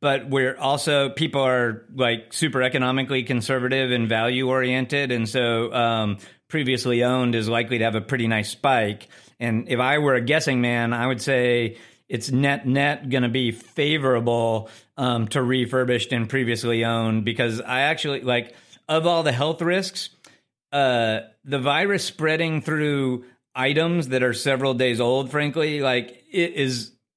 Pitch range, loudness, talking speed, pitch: 120-140 Hz, -22 LUFS, 160 wpm, 130 Hz